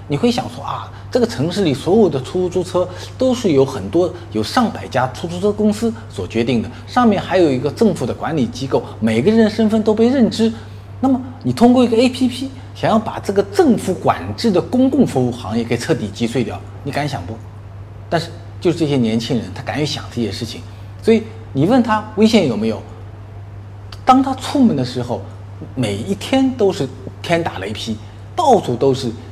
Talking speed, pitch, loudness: 285 characters per minute, 125 Hz, -17 LUFS